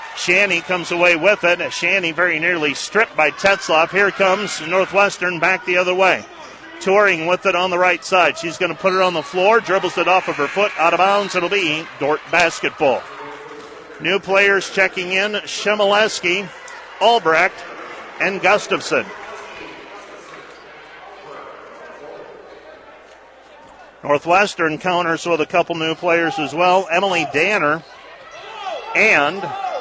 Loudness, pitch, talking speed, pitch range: -16 LUFS, 180 Hz, 135 wpm, 170-195 Hz